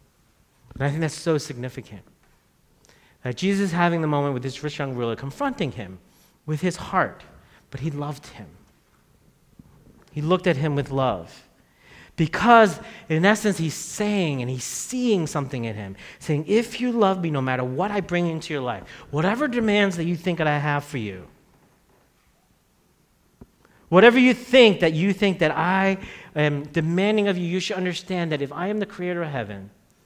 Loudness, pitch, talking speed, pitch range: -22 LUFS, 160 Hz, 180 wpm, 135-195 Hz